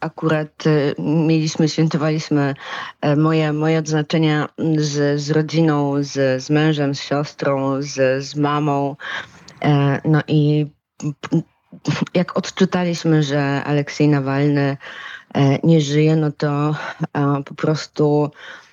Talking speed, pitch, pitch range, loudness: 95 wpm, 150 Hz, 145-155 Hz, -19 LUFS